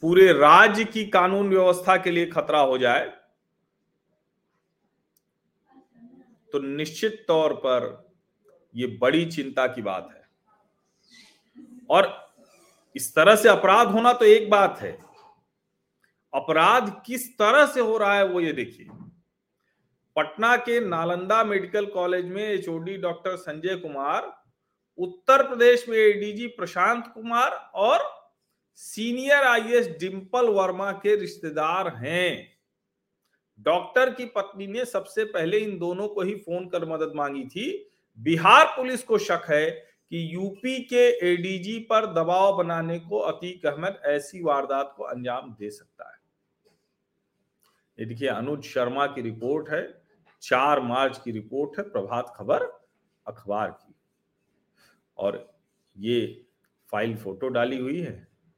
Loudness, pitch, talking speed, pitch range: -23 LUFS, 190 Hz, 125 wpm, 155-225 Hz